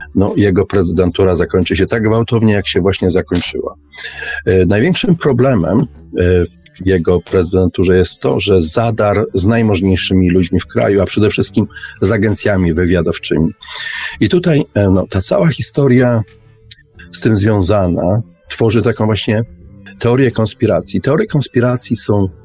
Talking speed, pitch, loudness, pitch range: 130 wpm, 100 Hz, -13 LUFS, 90-115 Hz